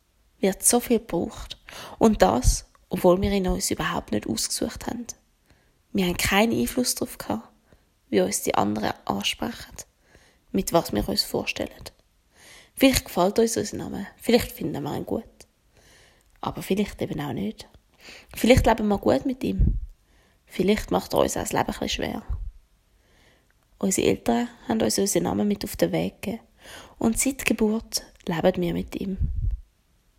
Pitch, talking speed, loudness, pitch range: 195 Hz, 155 wpm, -25 LUFS, 170-230 Hz